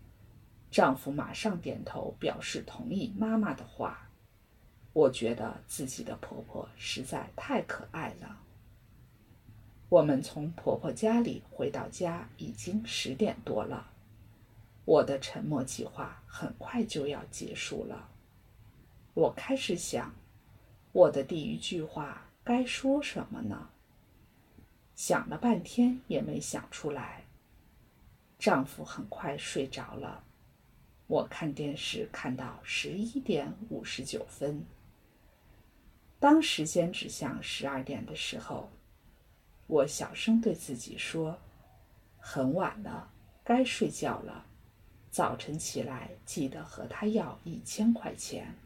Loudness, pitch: -33 LUFS, 160 Hz